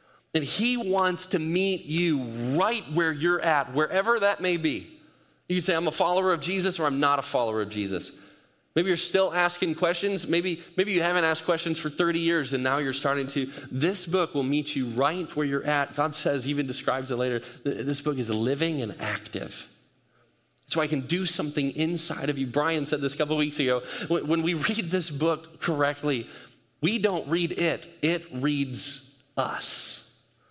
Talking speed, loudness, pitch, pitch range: 195 wpm, -26 LUFS, 155 Hz, 140-175 Hz